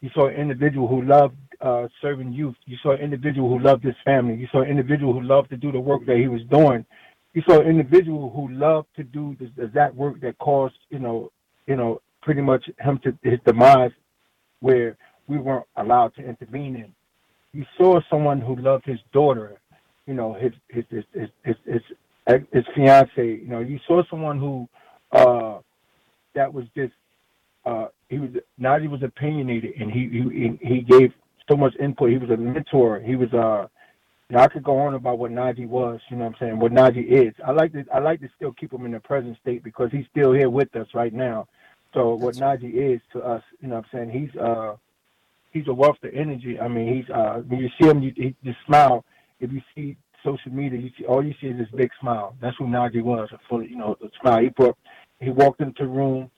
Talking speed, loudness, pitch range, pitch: 220 wpm, -21 LUFS, 120-140 Hz, 130 Hz